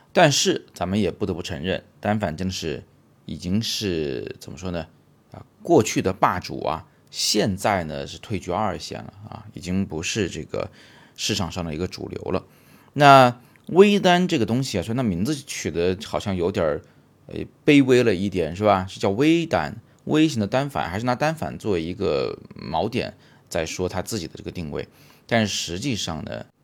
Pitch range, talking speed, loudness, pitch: 90-125 Hz, 265 characters per minute, -22 LUFS, 105 Hz